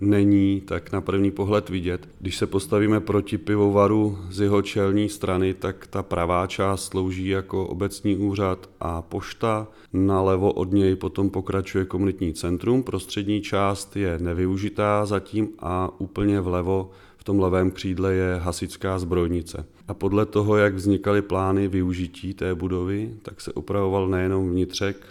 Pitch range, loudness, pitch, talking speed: 95-100 Hz, -24 LUFS, 95 Hz, 145 wpm